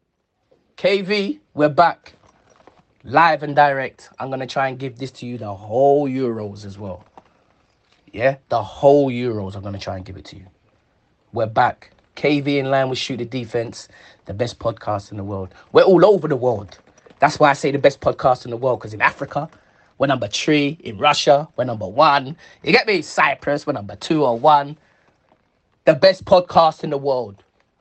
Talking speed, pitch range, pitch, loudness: 190 wpm, 110-145 Hz, 130 Hz, -18 LUFS